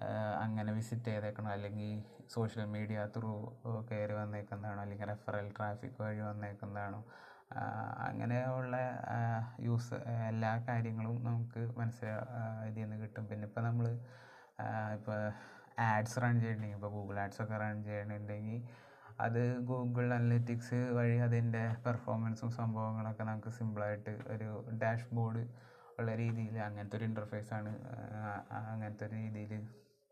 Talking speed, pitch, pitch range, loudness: 110 wpm, 110 Hz, 105-120 Hz, -39 LUFS